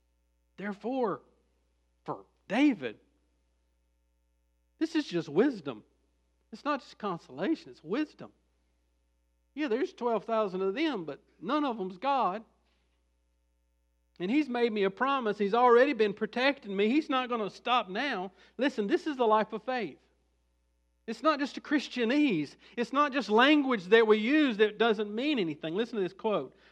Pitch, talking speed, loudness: 215 Hz, 150 wpm, -29 LUFS